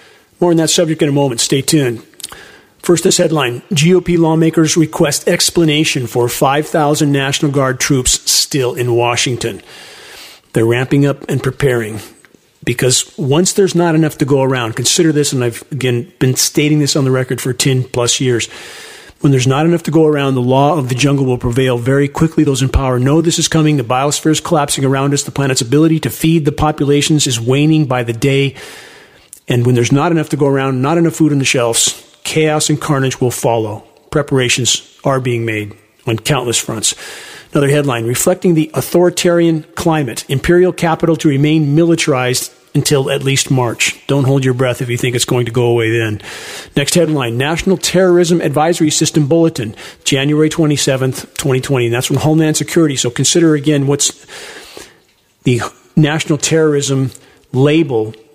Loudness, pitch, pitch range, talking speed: -13 LUFS, 140 Hz, 130-160 Hz, 175 wpm